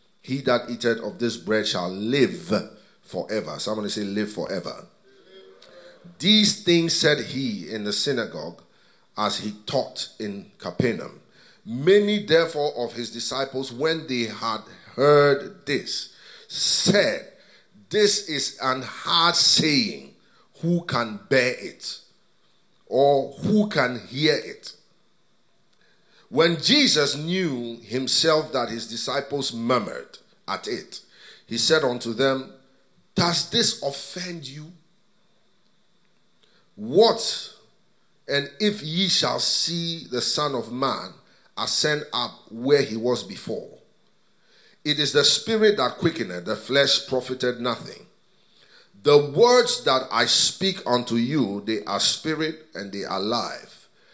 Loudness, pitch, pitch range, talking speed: -22 LUFS, 140 Hz, 120-175 Hz, 120 wpm